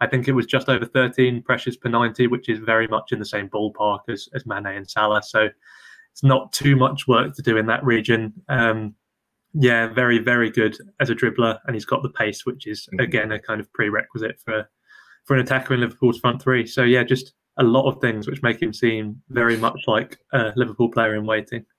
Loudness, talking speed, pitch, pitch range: -21 LUFS, 225 wpm, 120 Hz, 110-130 Hz